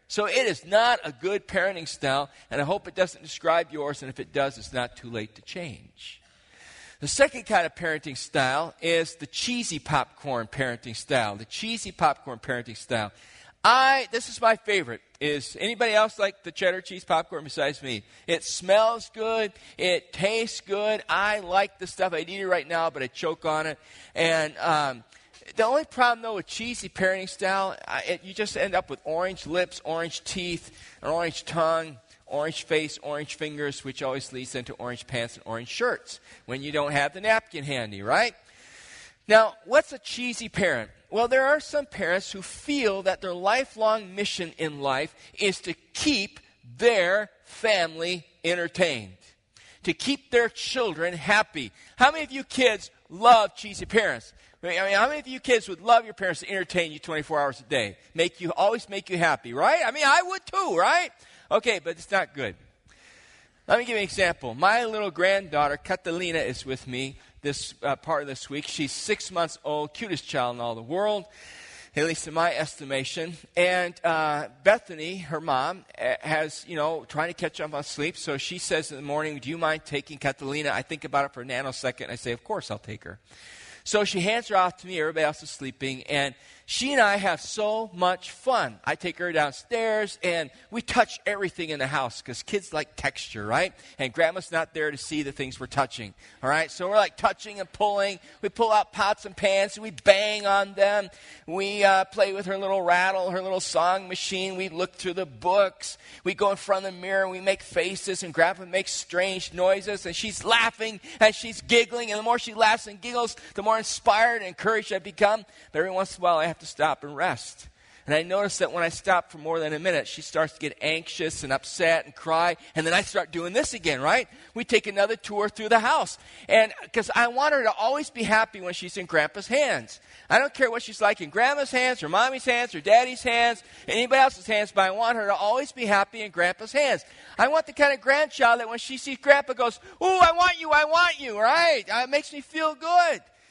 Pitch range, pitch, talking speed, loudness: 155-220 Hz, 185 Hz, 210 wpm, -25 LUFS